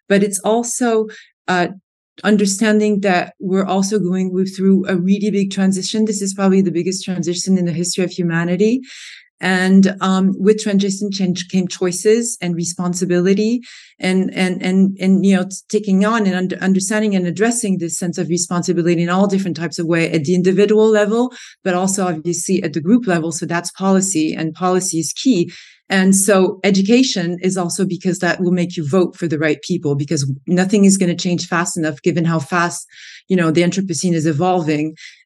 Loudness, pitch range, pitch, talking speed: -16 LUFS, 175-195 Hz, 185 Hz, 180 wpm